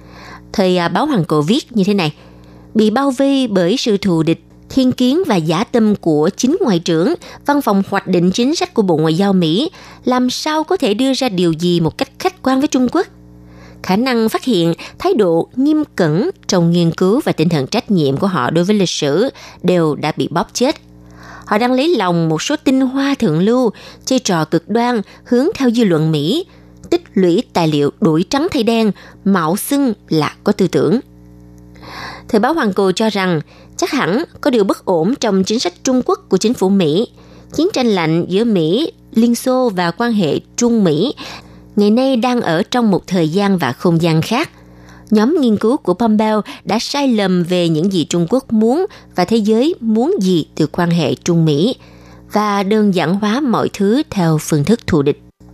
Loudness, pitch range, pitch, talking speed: -15 LUFS, 165-240 Hz, 195 Hz, 205 wpm